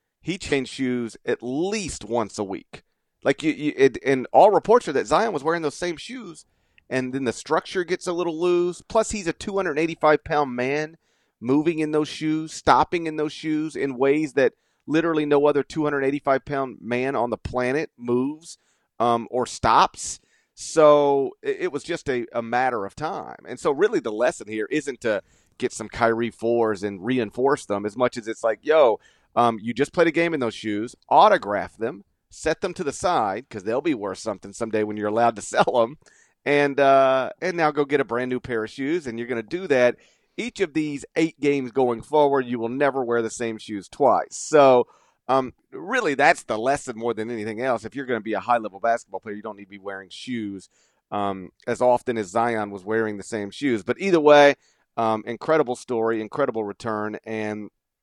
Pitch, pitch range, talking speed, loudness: 130 Hz, 115-155 Hz, 205 wpm, -23 LUFS